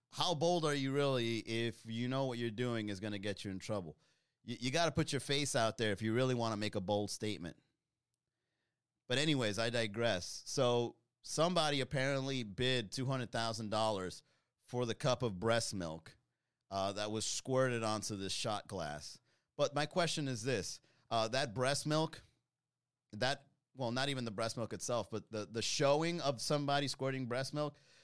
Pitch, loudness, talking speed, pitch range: 120 Hz, -37 LUFS, 180 wpm, 110-140 Hz